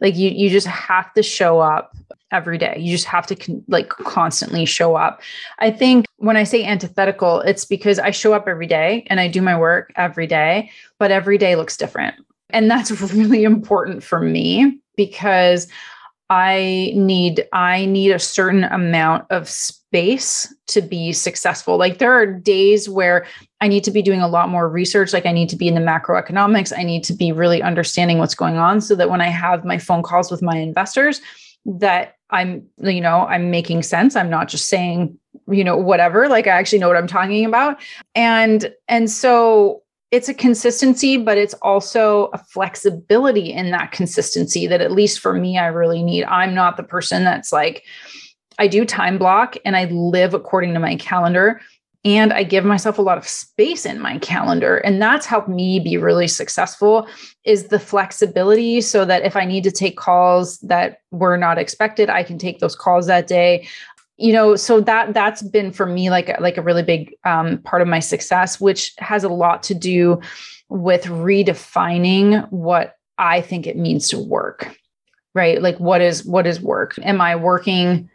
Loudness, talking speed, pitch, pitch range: -16 LUFS, 195 wpm, 185 Hz, 175-210 Hz